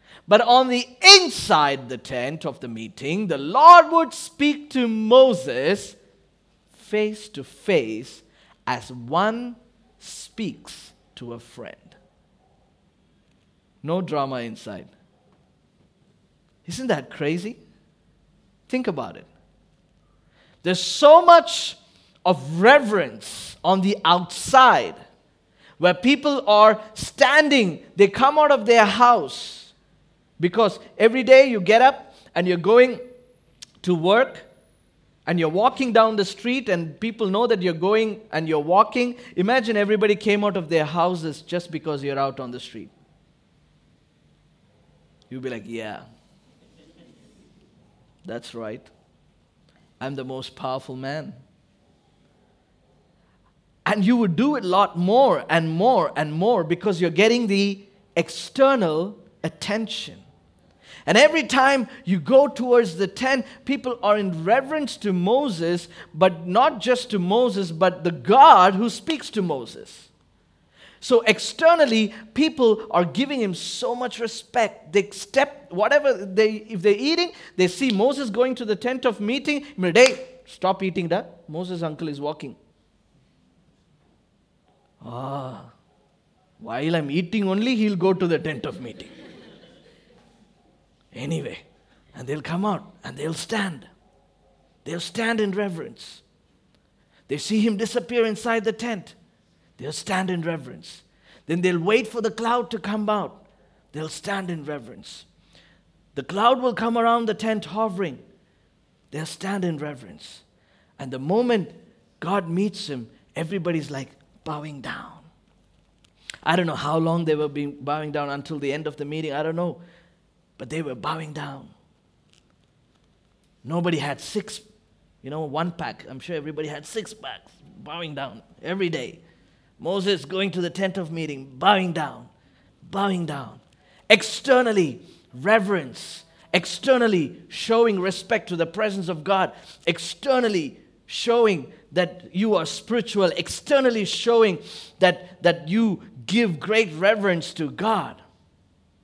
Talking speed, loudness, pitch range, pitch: 130 wpm, -21 LUFS, 160-230 Hz, 195 Hz